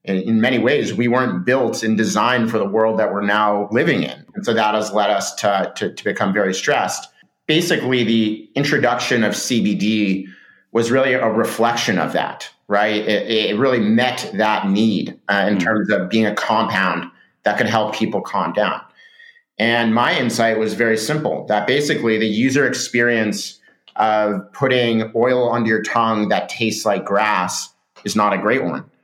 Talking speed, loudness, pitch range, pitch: 175 wpm, -18 LUFS, 105-120 Hz, 110 Hz